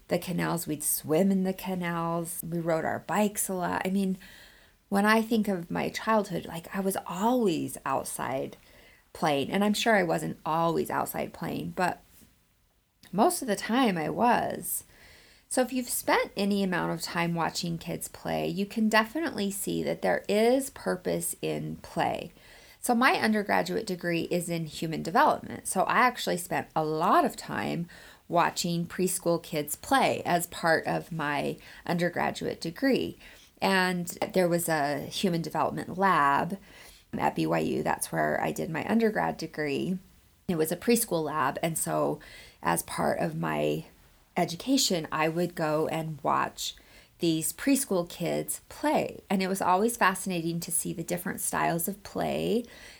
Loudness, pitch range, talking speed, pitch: -28 LUFS, 160-205 Hz, 155 wpm, 175 Hz